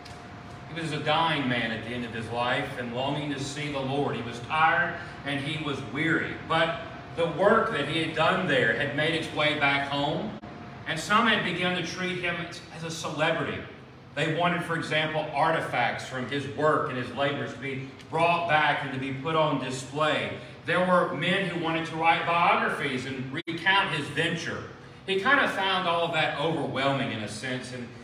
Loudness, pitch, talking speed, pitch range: -27 LUFS, 150 Hz, 200 wpm, 135-165 Hz